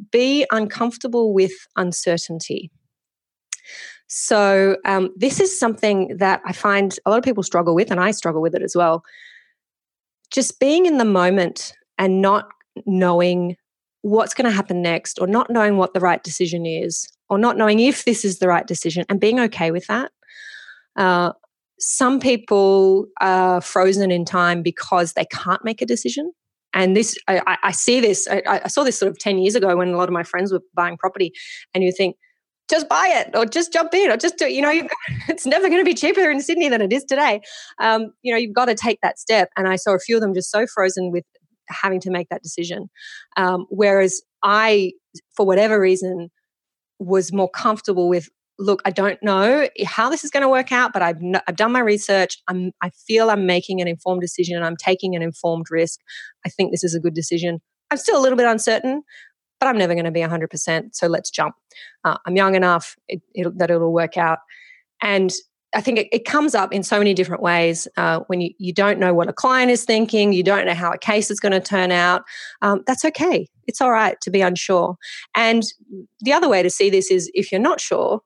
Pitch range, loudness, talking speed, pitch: 180-230 Hz, -19 LUFS, 215 wpm, 195 Hz